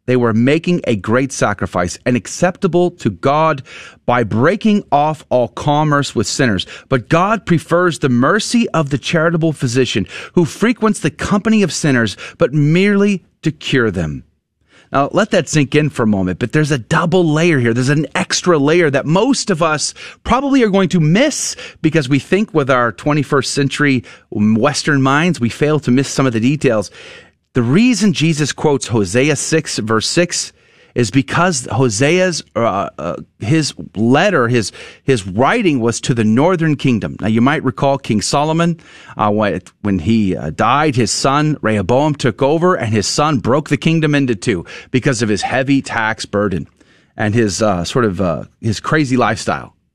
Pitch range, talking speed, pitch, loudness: 115-160 Hz, 170 wpm, 140 Hz, -15 LUFS